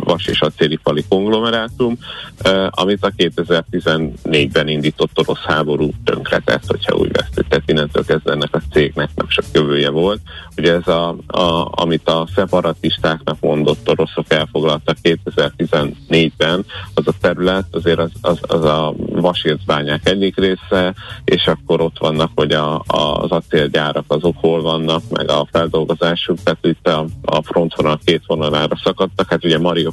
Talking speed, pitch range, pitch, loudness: 145 wpm, 75-90 Hz, 80 Hz, -16 LUFS